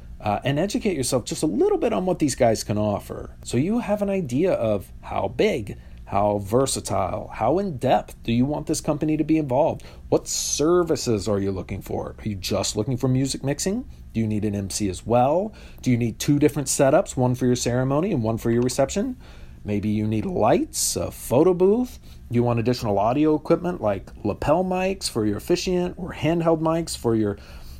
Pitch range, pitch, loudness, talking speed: 105-160 Hz, 125 Hz, -23 LUFS, 200 wpm